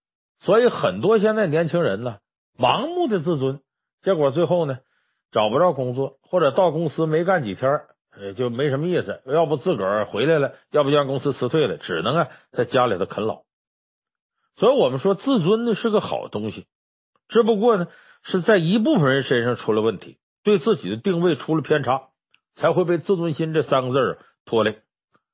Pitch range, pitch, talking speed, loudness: 135-195 Hz, 160 Hz, 285 characters per minute, -21 LUFS